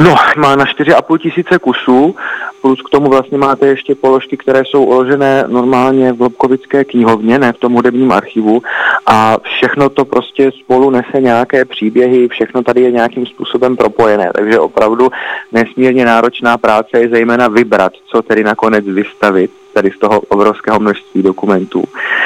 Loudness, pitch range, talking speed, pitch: -10 LUFS, 120-135 Hz, 155 wpm, 125 Hz